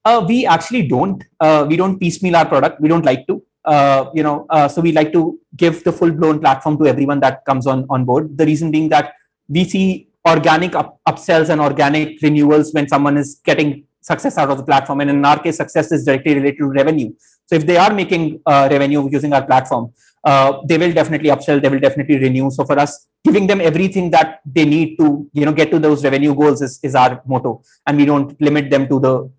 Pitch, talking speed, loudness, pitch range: 150 Hz, 230 wpm, -14 LUFS, 140-165 Hz